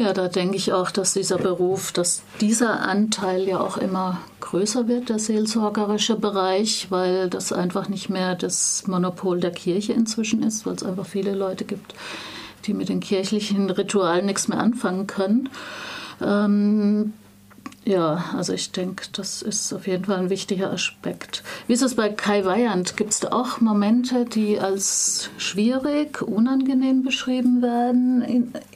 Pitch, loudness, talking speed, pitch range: 205 Hz, -22 LUFS, 155 wpm, 190-230 Hz